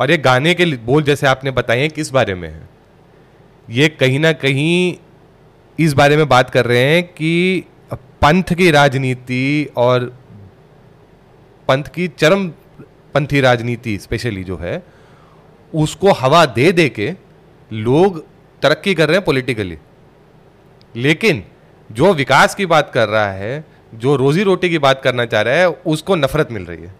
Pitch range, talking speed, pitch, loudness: 125-160 Hz, 155 wpm, 140 Hz, -15 LUFS